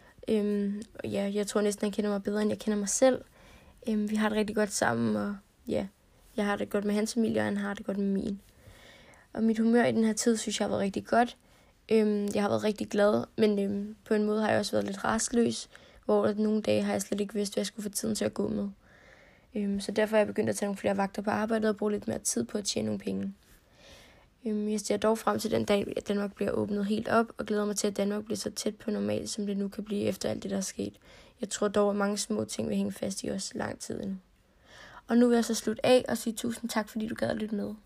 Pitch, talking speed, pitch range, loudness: 210 Hz, 275 wpm, 200-220 Hz, -30 LUFS